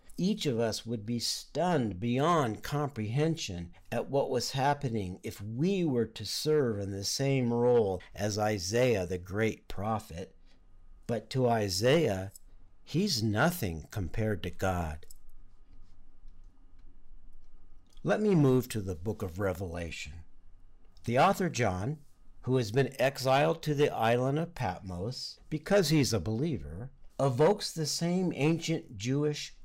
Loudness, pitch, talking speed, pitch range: -31 LUFS, 110 Hz, 130 wpm, 90-140 Hz